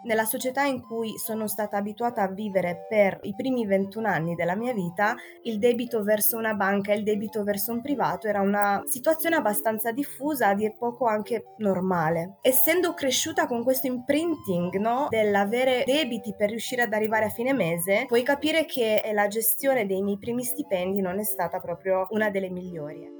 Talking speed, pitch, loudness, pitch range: 180 wpm, 215 Hz, -25 LUFS, 200-250 Hz